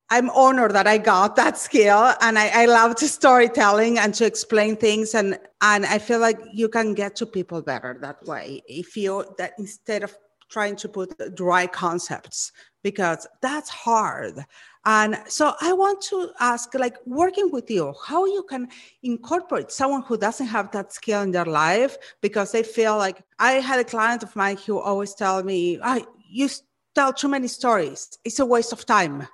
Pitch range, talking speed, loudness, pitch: 200-250 Hz, 190 wpm, -21 LUFS, 220 Hz